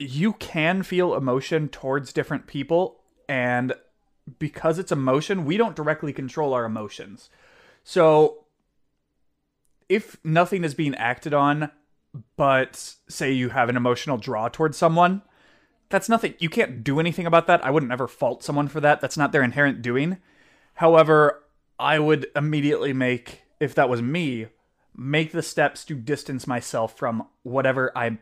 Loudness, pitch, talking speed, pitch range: -23 LUFS, 150 Hz, 150 wpm, 130-165 Hz